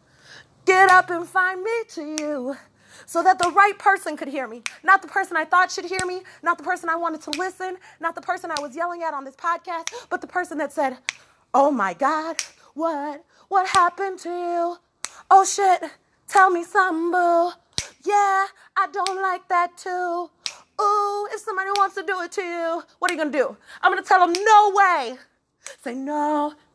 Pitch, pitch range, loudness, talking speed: 355 Hz, 325-385 Hz, -21 LUFS, 190 wpm